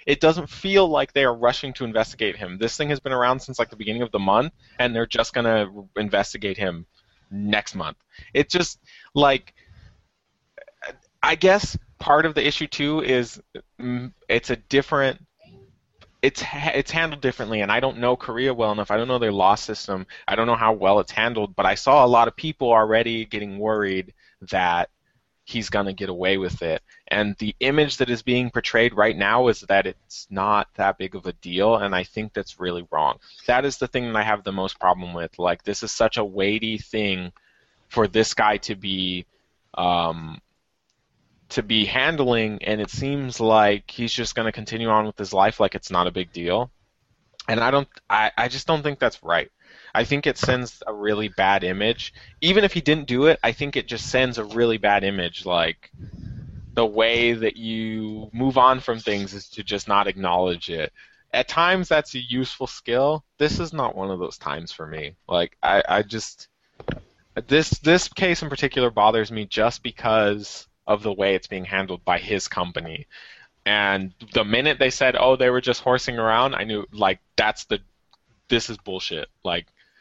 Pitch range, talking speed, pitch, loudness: 100-130 Hz, 195 wpm, 115 Hz, -22 LUFS